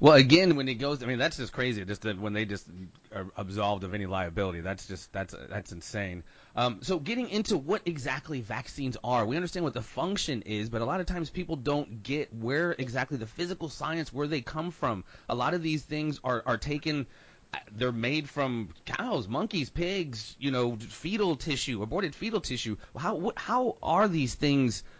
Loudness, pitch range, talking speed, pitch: -30 LUFS, 110-155 Hz, 200 wpm, 130 Hz